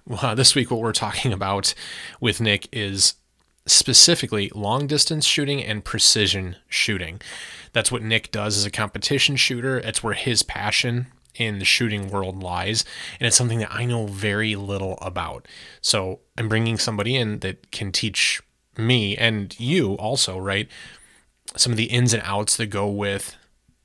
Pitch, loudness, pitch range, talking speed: 110 Hz, -20 LUFS, 100-120 Hz, 160 wpm